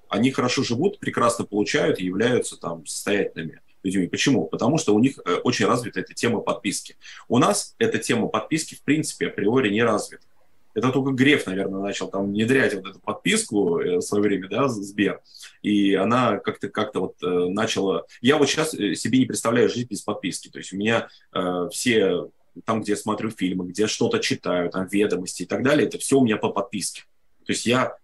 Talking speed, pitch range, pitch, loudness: 190 wpm, 95-130 Hz, 105 Hz, -23 LUFS